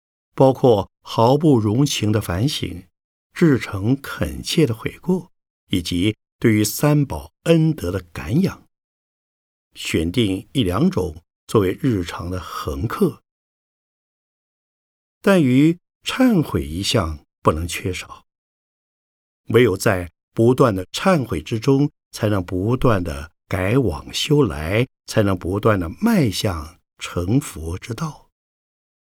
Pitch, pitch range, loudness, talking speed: 110 Hz, 90-140 Hz, -20 LUFS, 165 characters per minute